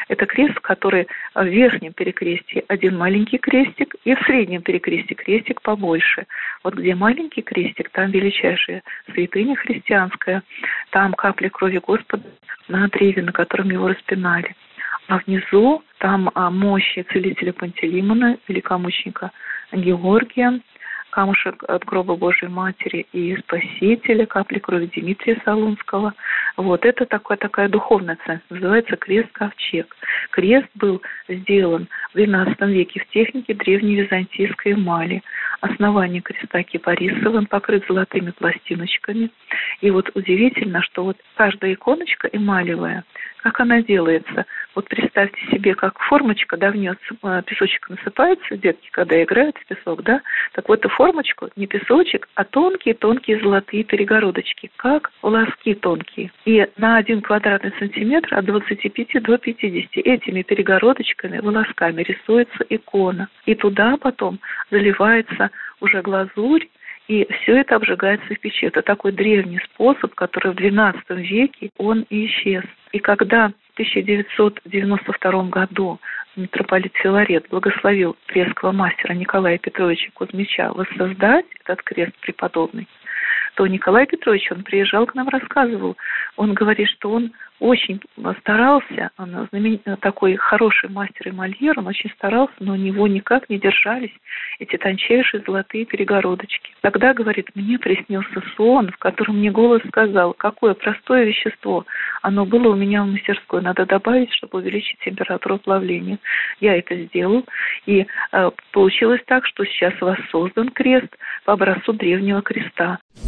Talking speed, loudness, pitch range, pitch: 130 wpm, -18 LUFS, 190-230 Hz, 205 Hz